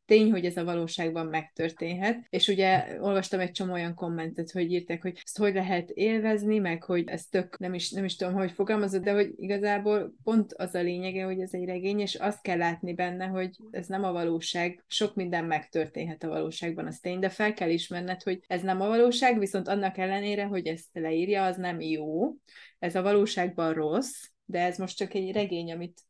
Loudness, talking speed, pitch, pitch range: -29 LUFS, 200 wpm, 185 Hz, 175-200 Hz